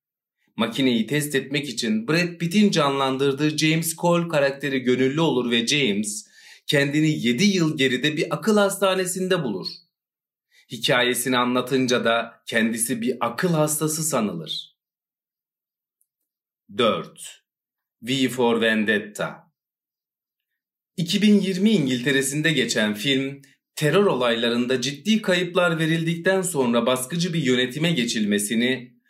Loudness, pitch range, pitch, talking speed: -22 LUFS, 125-175 Hz, 145 Hz, 100 wpm